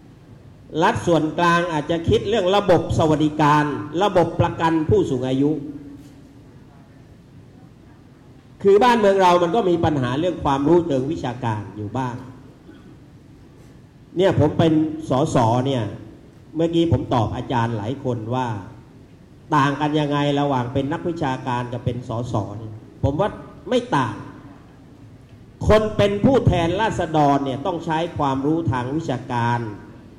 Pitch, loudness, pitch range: 140 Hz, -20 LUFS, 125-160 Hz